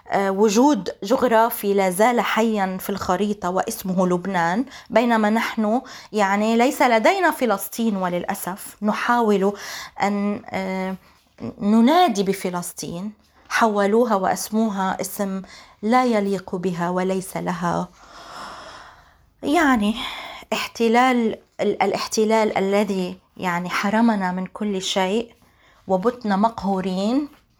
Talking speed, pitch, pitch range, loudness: 85 wpm, 205 Hz, 190-230 Hz, -21 LUFS